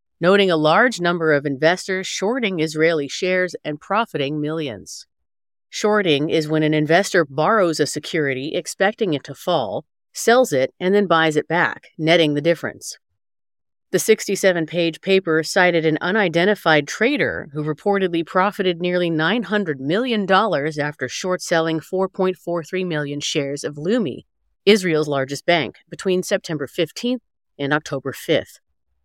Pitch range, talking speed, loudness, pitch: 150-190 Hz, 135 wpm, -19 LUFS, 165 Hz